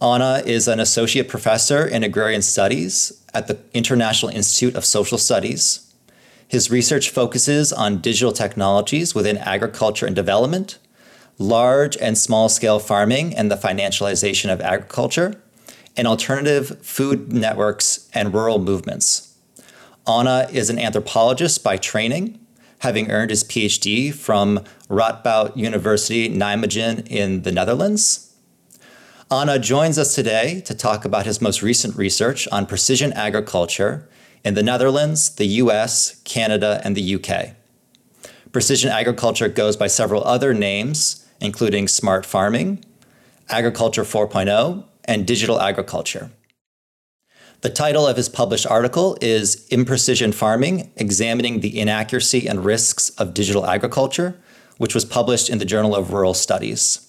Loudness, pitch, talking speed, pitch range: -18 LUFS, 115 Hz, 130 wpm, 105-130 Hz